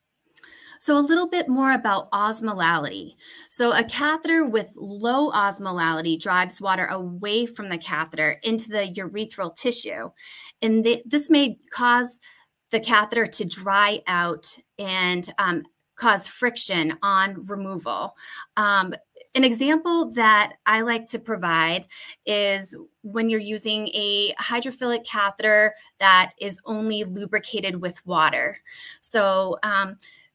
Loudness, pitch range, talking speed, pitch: -22 LUFS, 190-245 Hz, 125 wpm, 215 Hz